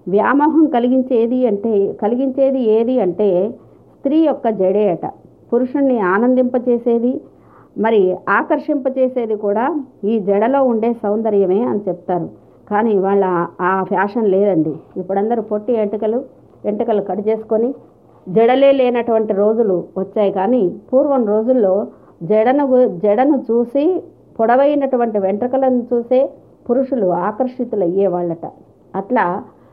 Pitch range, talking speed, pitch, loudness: 200-255 Hz, 100 wpm, 225 Hz, -16 LUFS